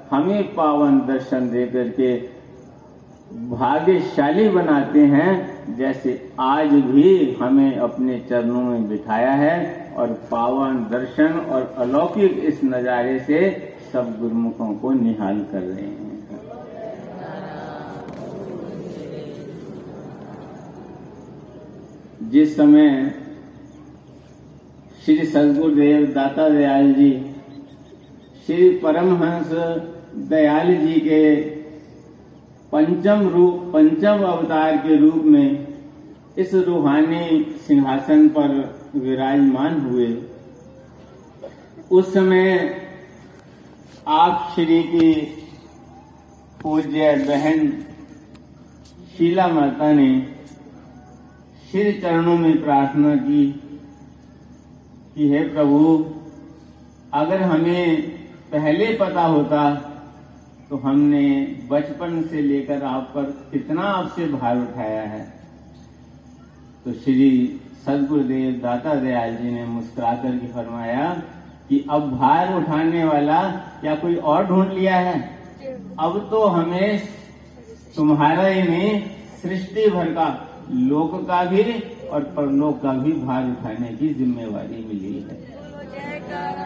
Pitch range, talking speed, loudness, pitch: 135-190 Hz, 95 wpm, -19 LUFS, 155 Hz